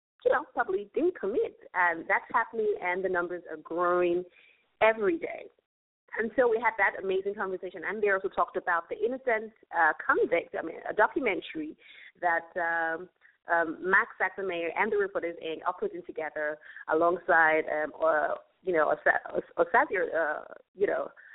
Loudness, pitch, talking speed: -29 LUFS, 190 Hz, 165 wpm